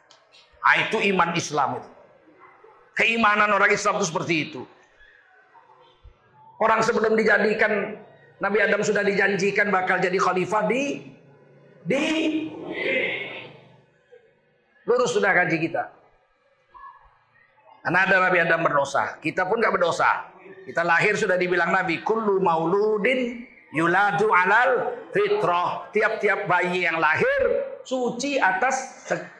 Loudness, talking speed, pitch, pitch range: -22 LUFS, 110 wpm, 205 Hz, 185-260 Hz